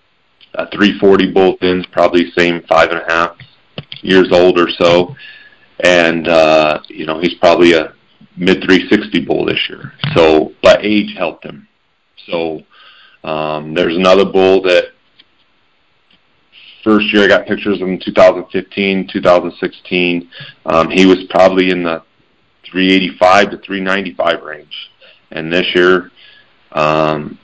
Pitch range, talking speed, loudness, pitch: 85-95 Hz, 130 wpm, -12 LUFS, 90 Hz